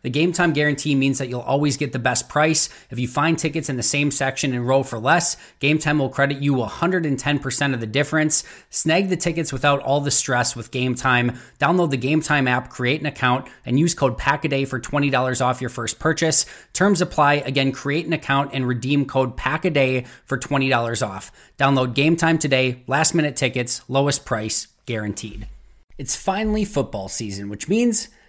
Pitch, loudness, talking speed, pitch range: 140 Hz, -20 LUFS, 190 wpm, 125-155 Hz